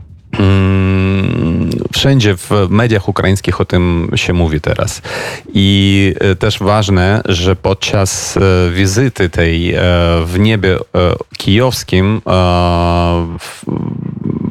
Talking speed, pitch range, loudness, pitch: 85 wpm, 90-105 Hz, -12 LUFS, 95 Hz